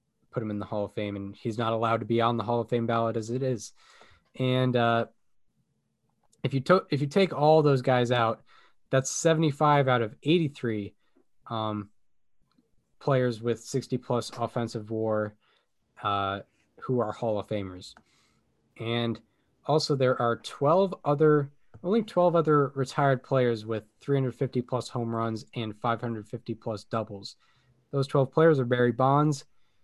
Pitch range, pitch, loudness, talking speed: 115-140 Hz, 120 Hz, -27 LUFS, 155 wpm